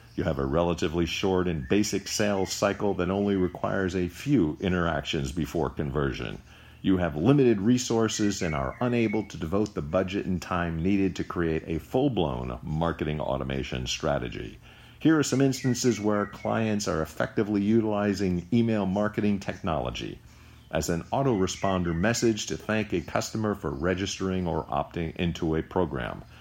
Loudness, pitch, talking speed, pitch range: -27 LUFS, 95 Hz, 150 wpm, 80-105 Hz